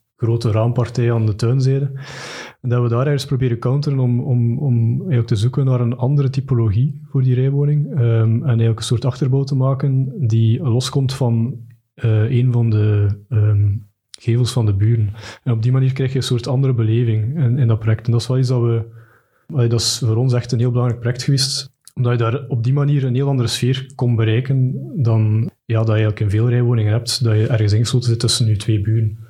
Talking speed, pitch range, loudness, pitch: 215 wpm, 115-130 Hz, -18 LUFS, 120 Hz